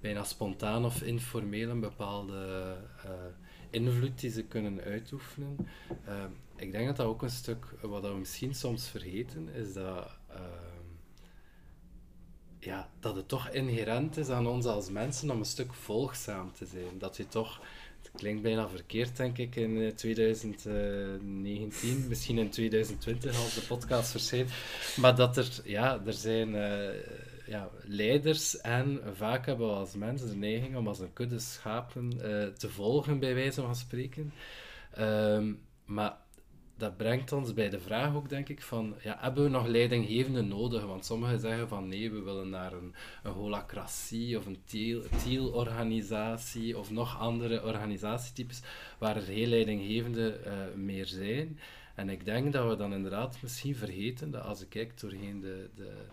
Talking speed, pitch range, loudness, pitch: 160 wpm, 105-125 Hz, -34 LUFS, 110 Hz